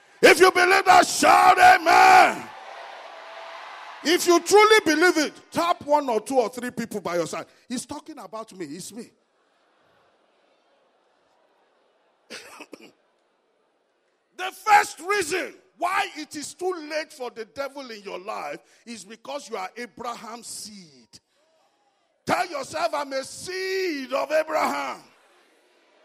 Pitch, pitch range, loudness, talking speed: 300 Hz, 235-370 Hz, -20 LUFS, 125 wpm